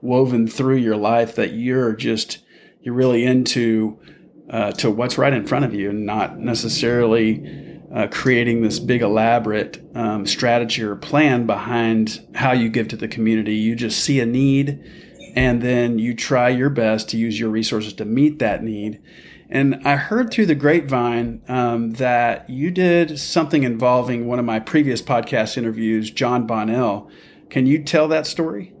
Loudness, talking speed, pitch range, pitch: -19 LUFS, 170 wpm, 110-130 Hz, 120 Hz